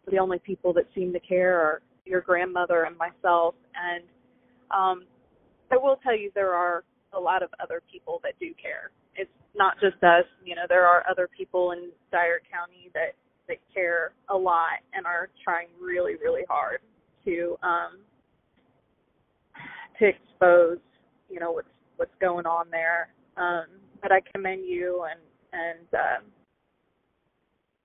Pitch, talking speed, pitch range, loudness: 180 Hz, 155 wpm, 175-195 Hz, -26 LUFS